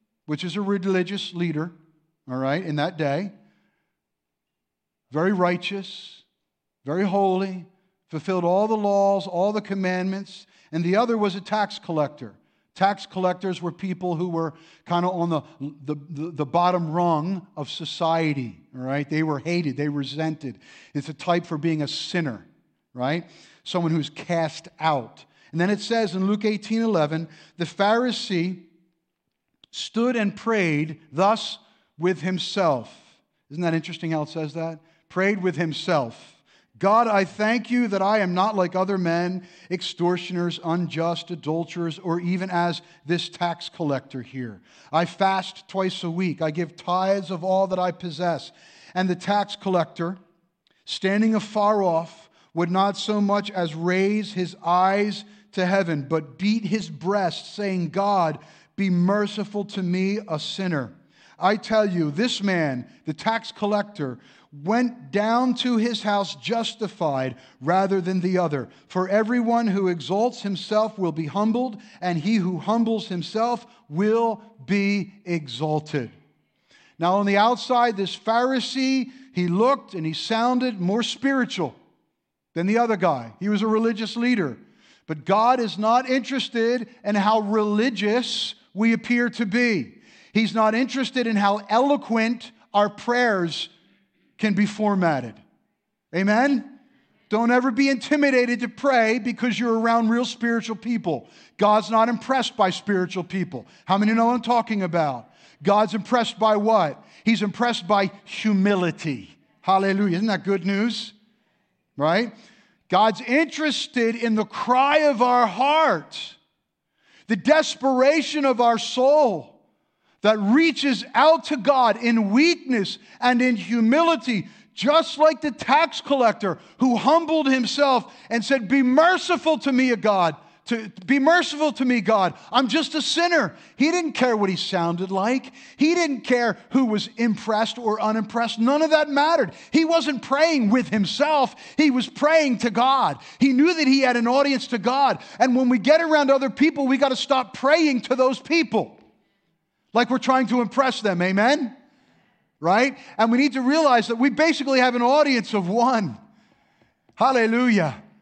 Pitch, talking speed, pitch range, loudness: 205 Hz, 150 wpm, 175-240 Hz, -22 LUFS